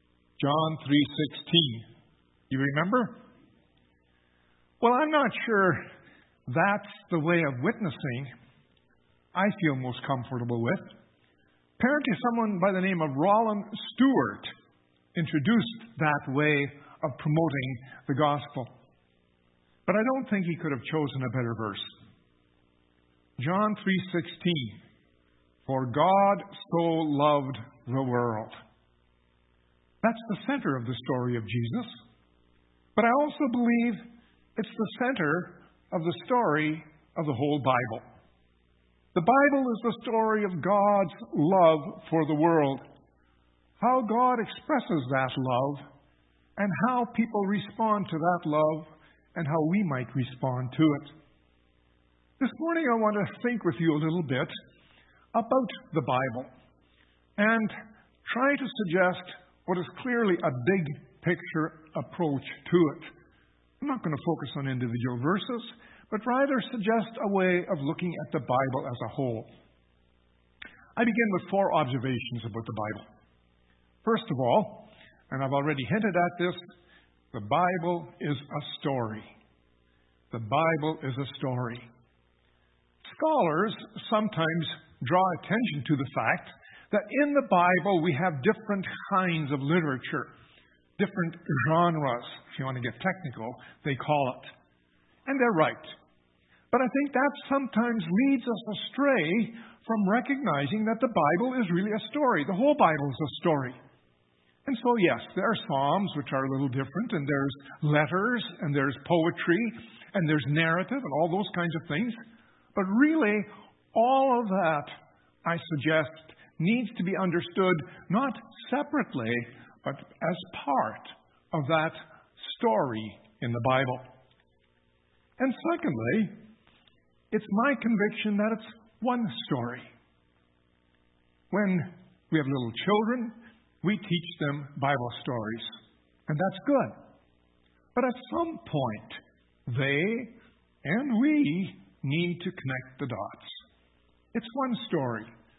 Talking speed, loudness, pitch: 130 wpm, -28 LUFS, 160 Hz